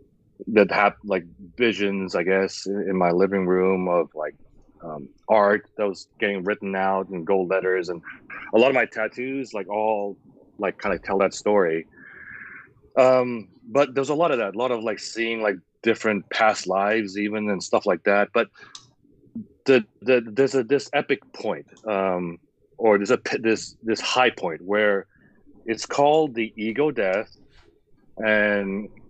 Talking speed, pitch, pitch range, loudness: 165 wpm, 105 Hz, 95-115 Hz, -23 LUFS